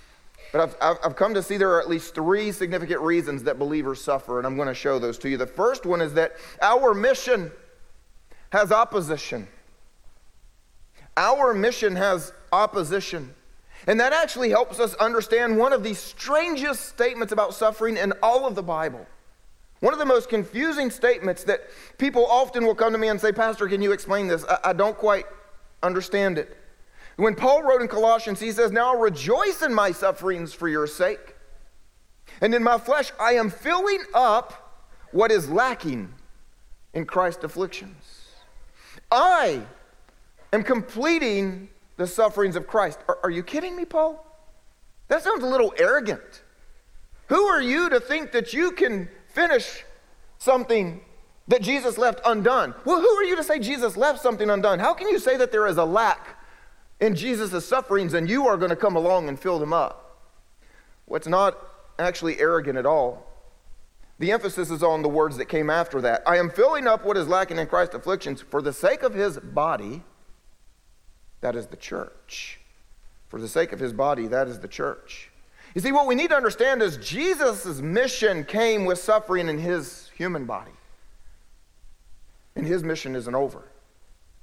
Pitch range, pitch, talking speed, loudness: 170-245 Hz, 205 Hz, 175 wpm, -23 LUFS